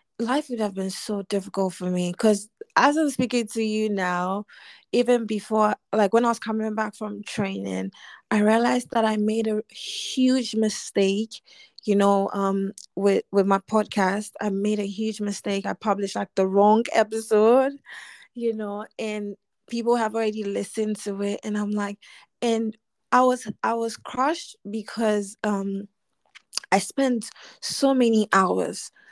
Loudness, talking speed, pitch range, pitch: -24 LUFS, 155 wpm, 200-230 Hz, 215 Hz